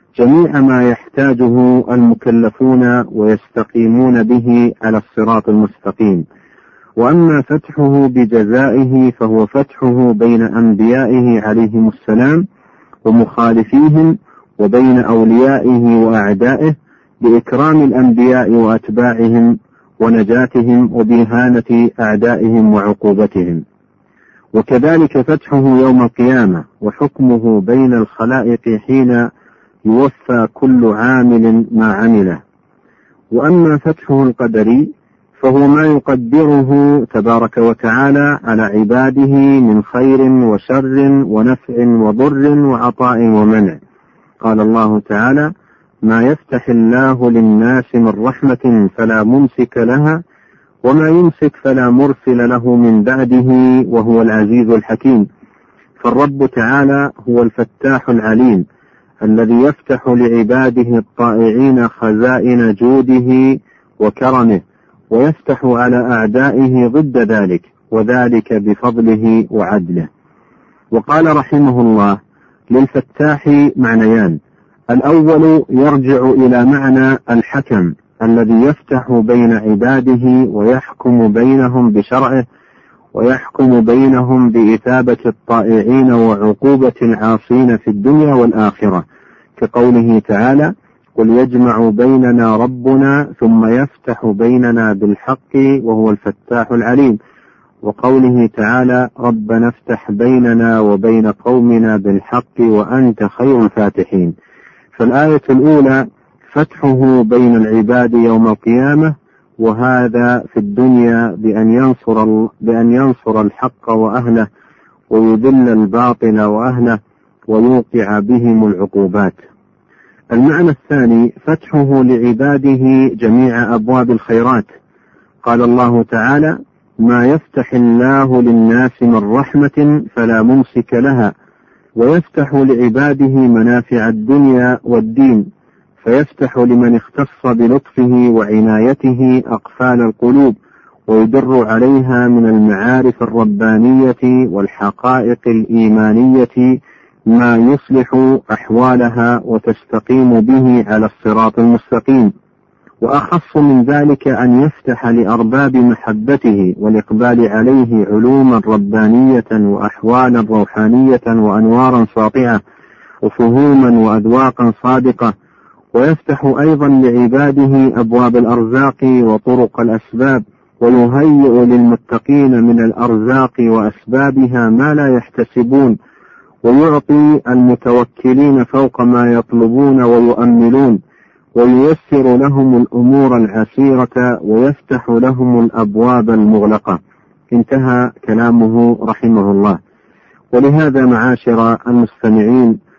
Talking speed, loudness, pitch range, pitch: 85 wpm, -10 LUFS, 115-130 Hz, 120 Hz